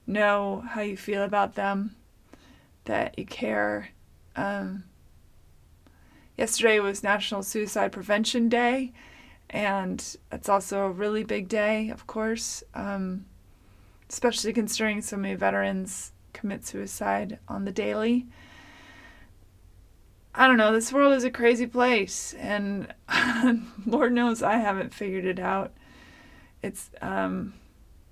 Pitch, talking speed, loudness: 205 Hz, 115 wpm, -26 LUFS